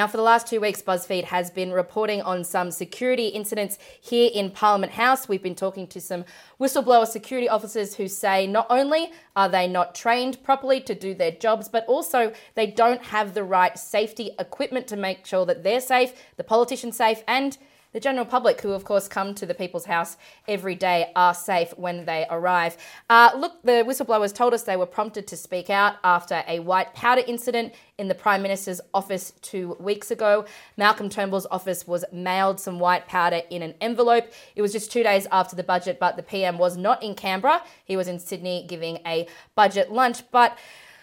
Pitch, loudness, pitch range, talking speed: 205 Hz, -23 LUFS, 185-235 Hz, 200 wpm